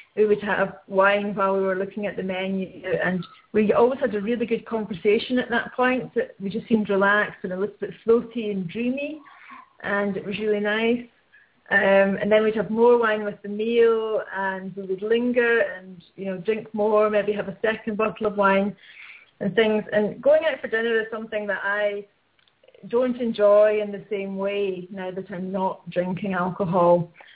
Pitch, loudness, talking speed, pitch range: 210 Hz, -23 LUFS, 190 wpm, 195-225 Hz